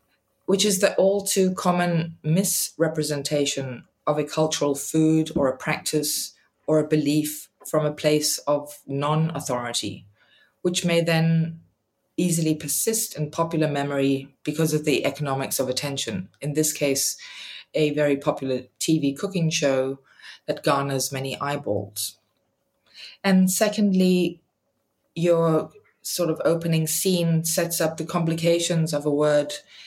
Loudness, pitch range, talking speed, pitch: -23 LUFS, 140-170 Hz, 130 wpm, 155 Hz